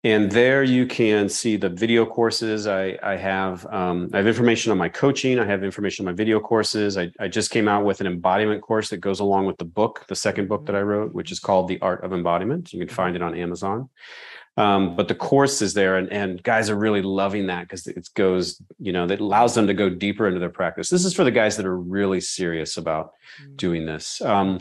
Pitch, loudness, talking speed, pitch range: 100 Hz, -22 LUFS, 240 wpm, 95-110 Hz